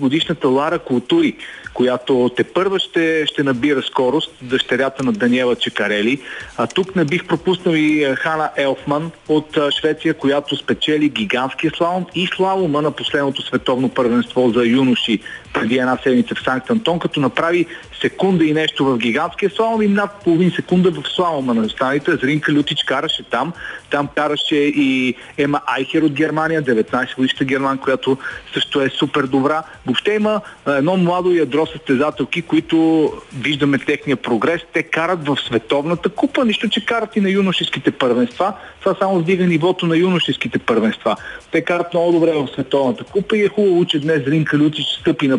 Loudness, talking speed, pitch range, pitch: -17 LUFS, 160 wpm, 135-175 Hz, 155 Hz